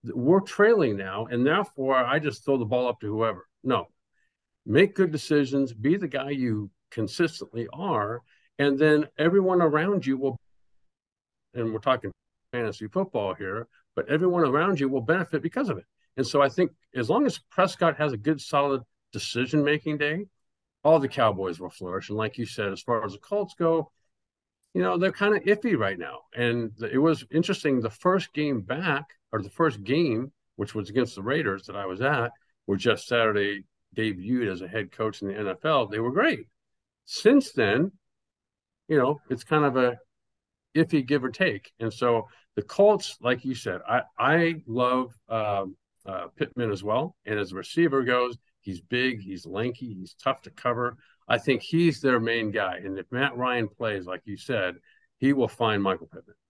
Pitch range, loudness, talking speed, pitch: 110-155 Hz, -26 LUFS, 185 wpm, 125 Hz